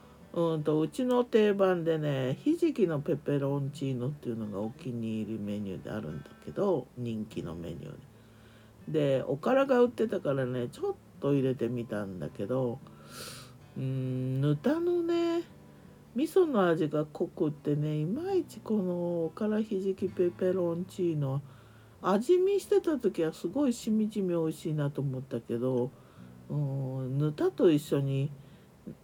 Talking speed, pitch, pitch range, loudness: 290 characters per minute, 150 Hz, 130-195 Hz, -31 LUFS